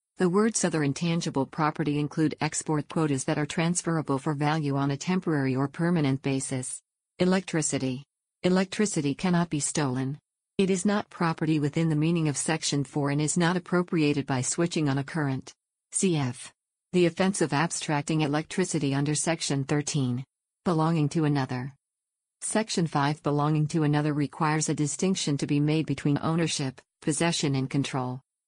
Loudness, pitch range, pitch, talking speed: -27 LUFS, 140-170 Hz, 150 Hz, 150 wpm